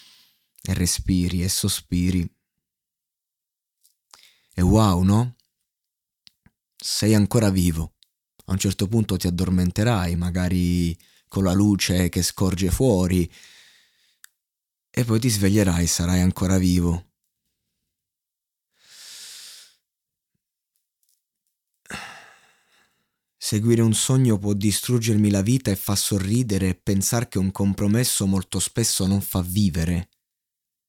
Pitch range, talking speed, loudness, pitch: 90-105 Hz, 100 wpm, -22 LUFS, 95 Hz